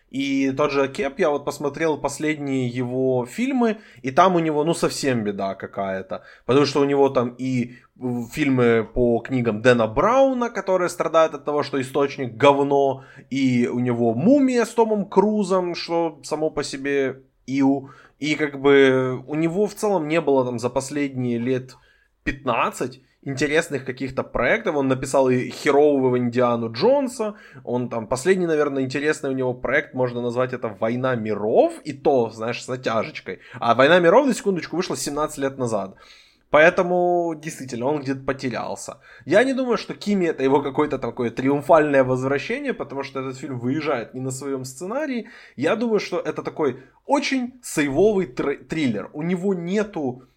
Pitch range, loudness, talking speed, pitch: 130-165 Hz, -22 LUFS, 160 wpm, 140 Hz